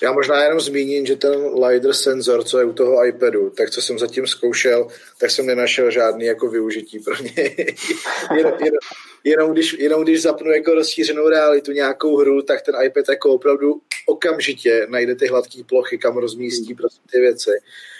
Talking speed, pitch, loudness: 175 wpm, 155 Hz, -17 LUFS